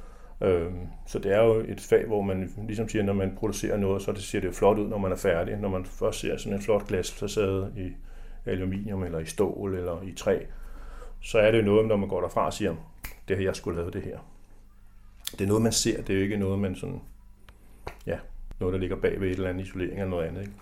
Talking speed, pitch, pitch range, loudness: 255 wpm, 95 Hz, 90-100 Hz, -28 LUFS